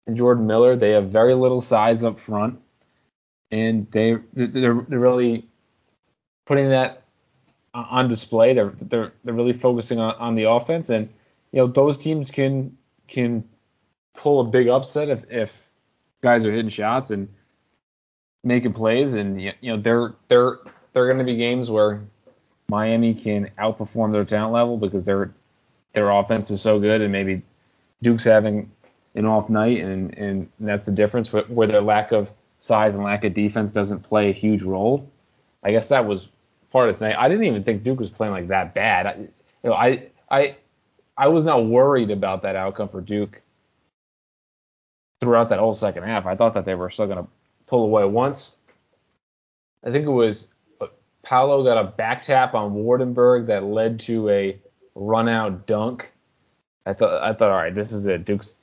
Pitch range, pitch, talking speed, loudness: 105-125 Hz, 110 Hz, 180 wpm, -20 LUFS